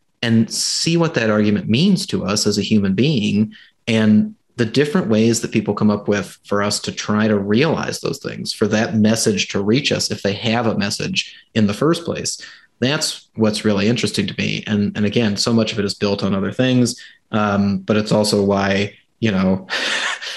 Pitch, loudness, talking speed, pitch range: 110 Hz, -18 LUFS, 205 wpm, 105-125 Hz